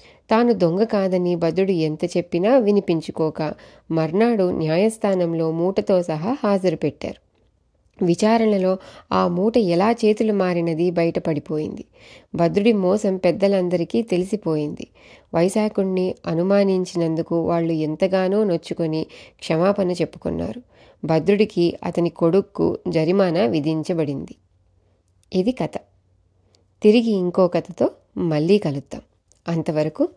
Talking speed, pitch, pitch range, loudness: 90 wpm, 175 Hz, 155-195 Hz, -20 LUFS